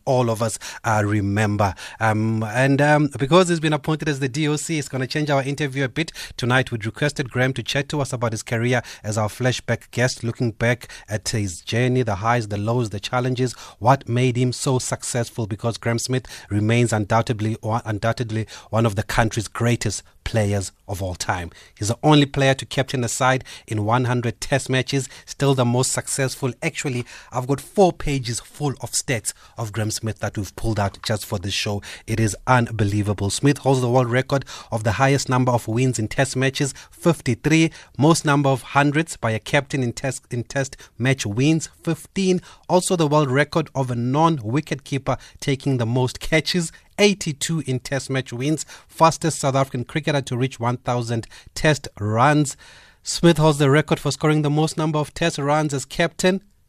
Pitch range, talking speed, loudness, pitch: 115-145 Hz, 185 wpm, -21 LUFS, 130 Hz